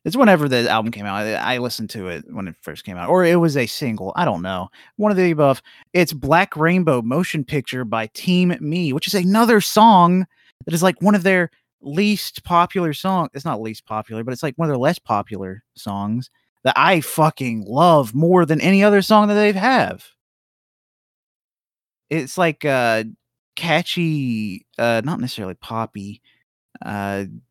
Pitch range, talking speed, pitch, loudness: 115-180 Hz, 180 wpm, 155 Hz, -18 LUFS